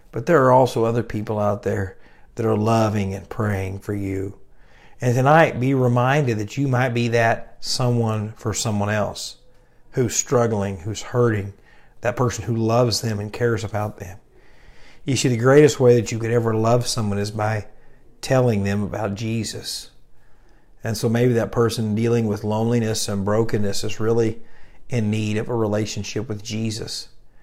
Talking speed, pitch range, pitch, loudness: 170 wpm, 105-120 Hz, 110 Hz, -21 LUFS